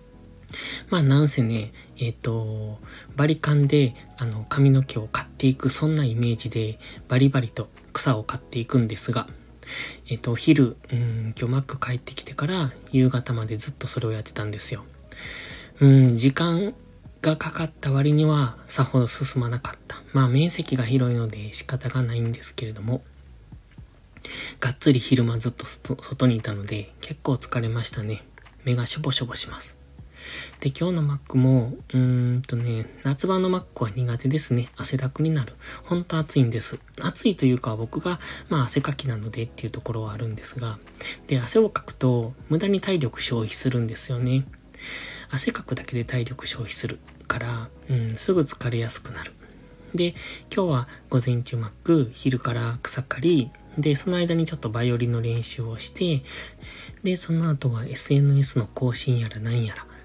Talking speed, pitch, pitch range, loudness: 330 characters per minute, 125 Hz, 115-140 Hz, -24 LUFS